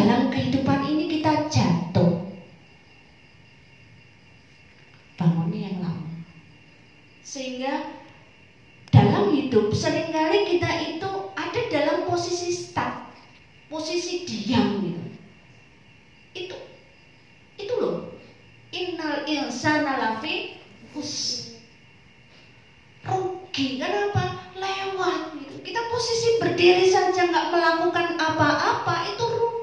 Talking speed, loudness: 85 wpm, -24 LUFS